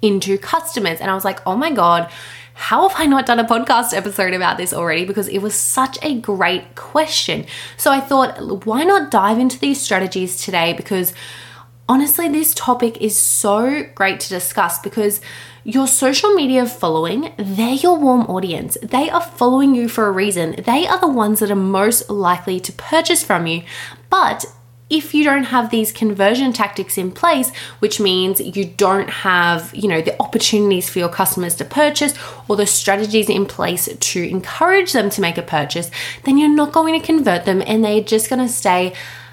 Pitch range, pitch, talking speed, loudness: 190-265 Hz, 210 Hz, 190 wpm, -16 LUFS